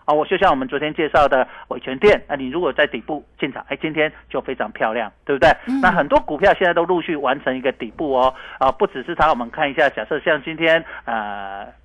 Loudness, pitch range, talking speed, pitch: -19 LUFS, 130-170 Hz, 350 characters per minute, 155 Hz